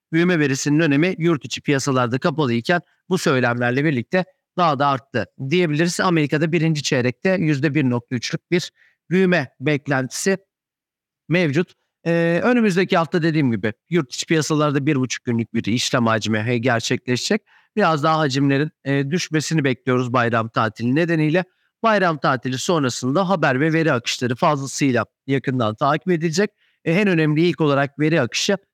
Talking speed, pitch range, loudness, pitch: 135 wpm, 130-175 Hz, -20 LUFS, 155 Hz